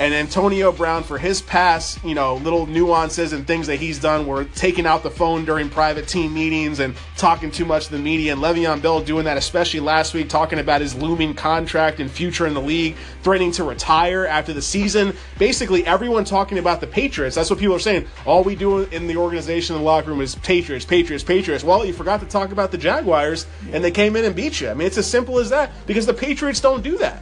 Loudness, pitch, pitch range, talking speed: -19 LUFS, 165 Hz, 155-190 Hz, 240 wpm